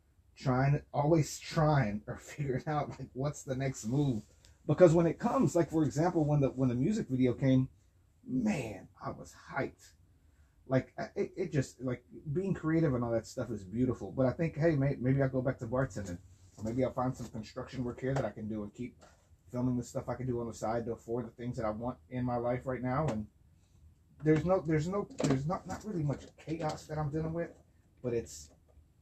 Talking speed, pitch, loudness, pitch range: 215 wpm, 125 Hz, -33 LUFS, 110-145 Hz